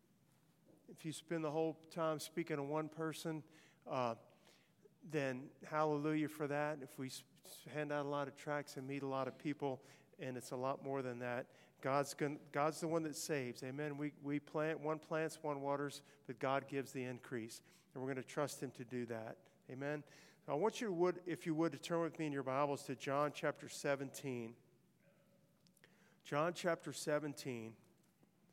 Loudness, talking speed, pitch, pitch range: -43 LUFS, 185 wpm, 150 Hz, 135-160 Hz